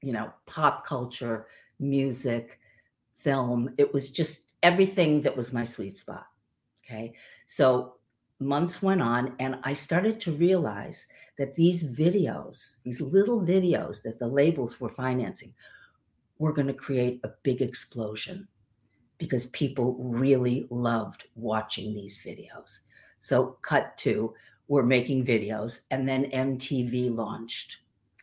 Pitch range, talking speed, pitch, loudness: 120-145 Hz, 130 wpm, 130 Hz, -28 LUFS